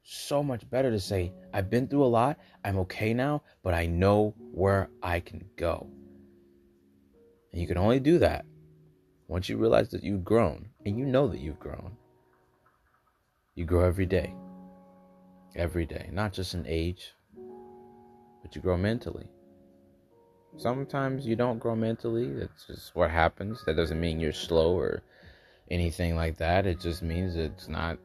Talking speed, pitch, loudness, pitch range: 160 wpm, 95 Hz, -29 LUFS, 80-115 Hz